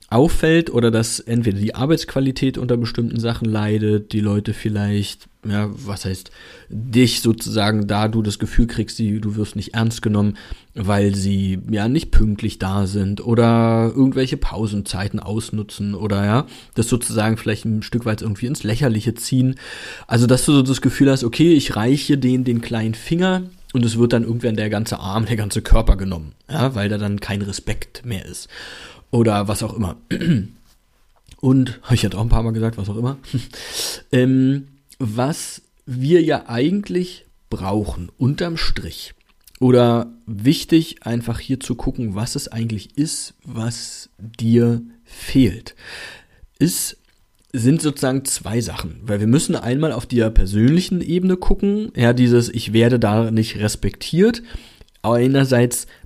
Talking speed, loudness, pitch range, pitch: 155 wpm, -19 LUFS, 105-130 Hz, 115 Hz